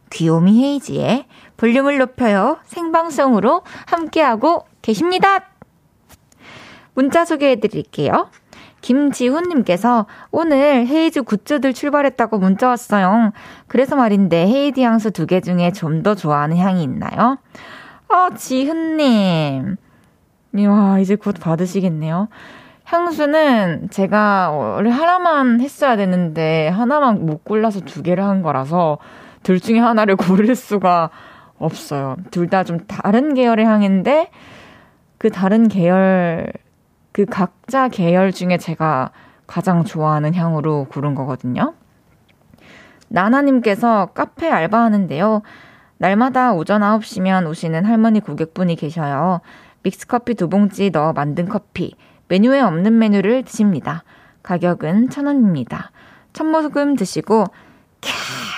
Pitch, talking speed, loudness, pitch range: 210 Hz, 265 characters per minute, -16 LUFS, 180-255 Hz